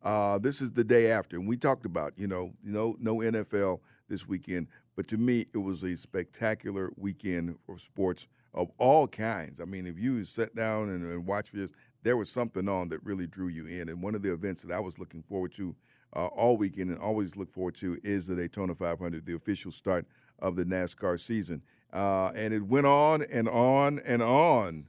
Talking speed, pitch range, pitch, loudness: 210 wpm, 90-110 Hz, 95 Hz, -31 LUFS